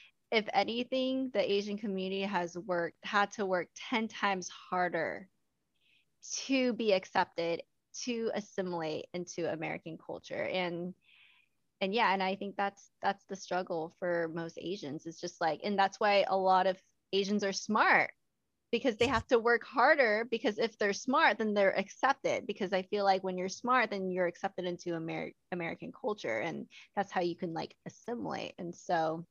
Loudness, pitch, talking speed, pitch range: -33 LUFS, 195 Hz, 170 wpm, 180-220 Hz